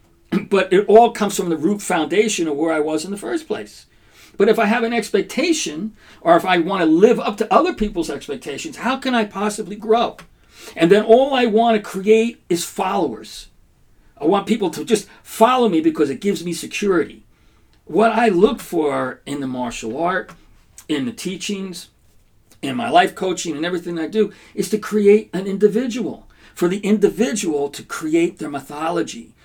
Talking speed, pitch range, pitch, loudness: 185 wpm, 165-225 Hz, 200 Hz, -18 LUFS